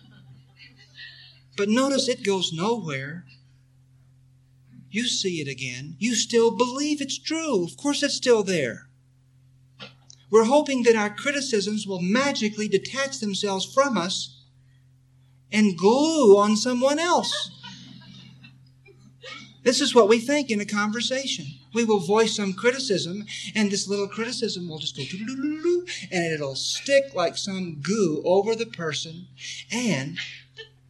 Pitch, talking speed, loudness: 195 Hz, 125 wpm, -23 LUFS